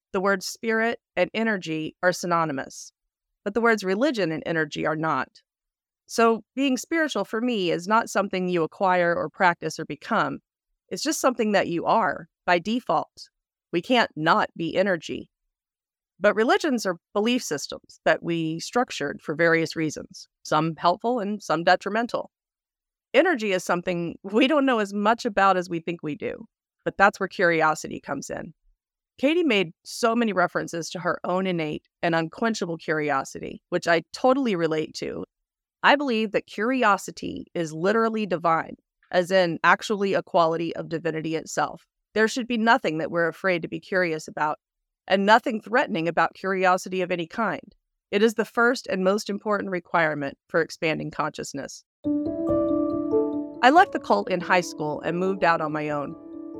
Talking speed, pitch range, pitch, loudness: 160 wpm, 165-230 Hz, 190 Hz, -24 LUFS